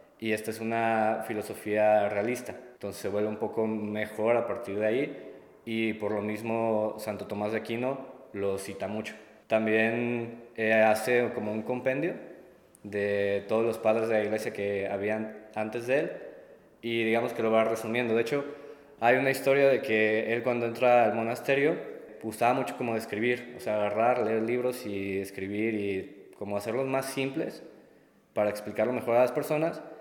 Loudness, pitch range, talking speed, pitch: -29 LUFS, 105-125 Hz, 170 wpm, 110 Hz